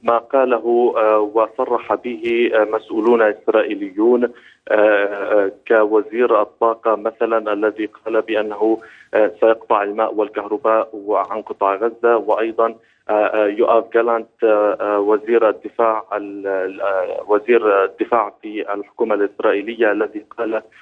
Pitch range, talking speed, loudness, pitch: 105-115 Hz, 85 wpm, -18 LUFS, 110 Hz